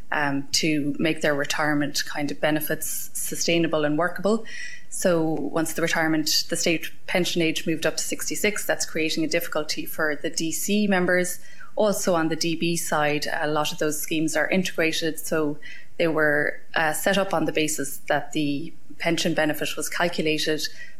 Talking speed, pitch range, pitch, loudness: 165 wpm, 150-170 Hz, 160 Hz, -24 LUFS